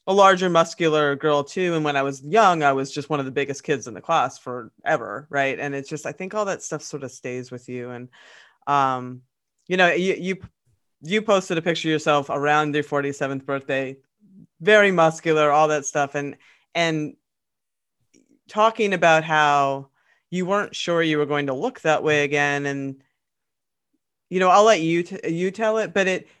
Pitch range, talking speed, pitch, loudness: 140-185 Hz, 195 wpm, 150 Hz, -21 LUFS